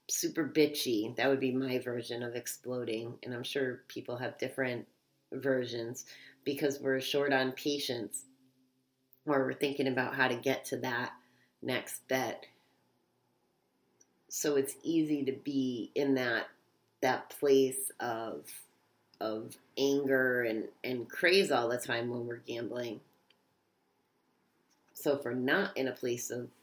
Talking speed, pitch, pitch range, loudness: 135 wpm, 130 Hz, 120-140 Hz, -33 LUFS